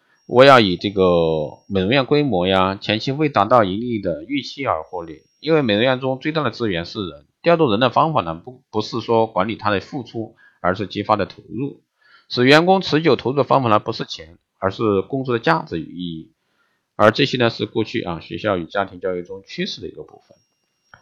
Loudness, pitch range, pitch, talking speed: -19 LUFS, 95-140 Hz, 110 Hz, 310 characters per minute